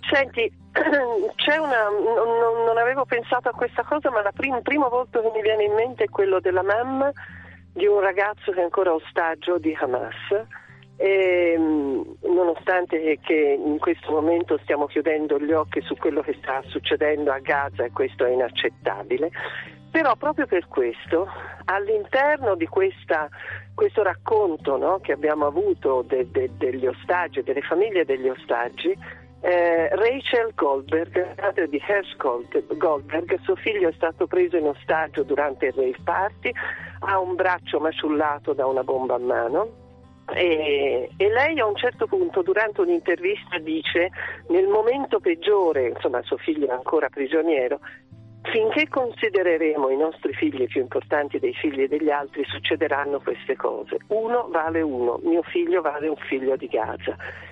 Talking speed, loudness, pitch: 150 wpm, -23 LUFS, 215 Hz